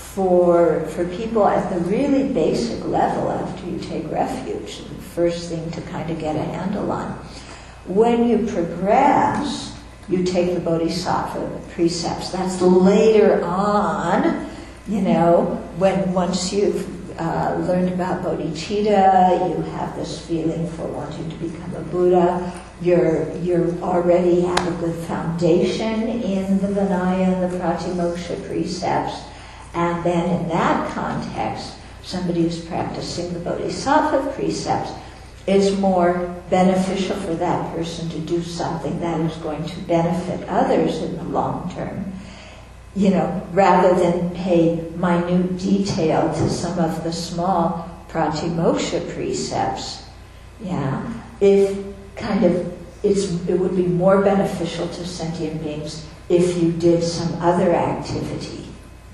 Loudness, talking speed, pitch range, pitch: -20 LUFS, 130 wpm, 165-190 Hz, 175 Hz